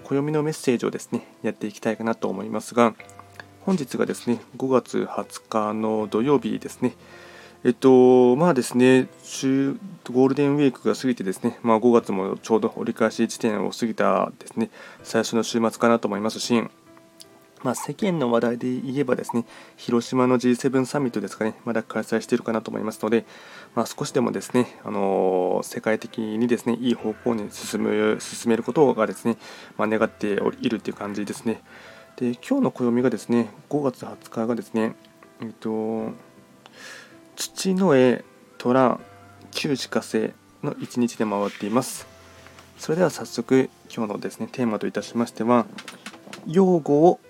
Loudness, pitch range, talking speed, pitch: -23 LUFS, 110-125 Hz, 300 characters per minute, 115 Hz